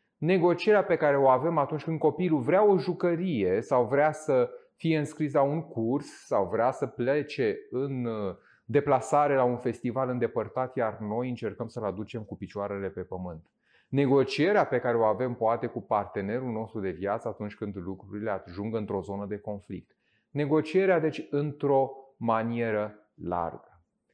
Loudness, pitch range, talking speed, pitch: -28 LUFS, 105-150 Hz, 155 wpm, 125 Hz